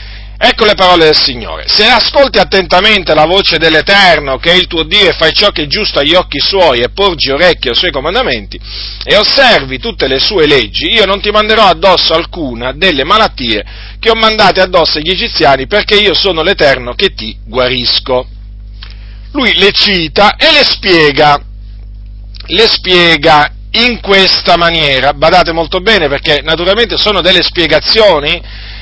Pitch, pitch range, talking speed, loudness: 165 Hz, 130-200 Hz, 160 wpm, -7 LUFS